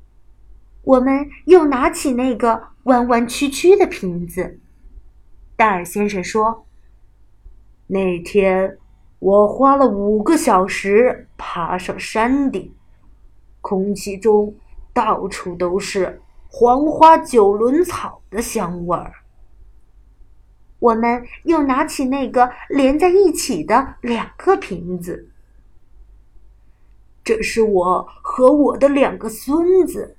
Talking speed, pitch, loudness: 145 characters per minute, 205 Hz, -17 LUFS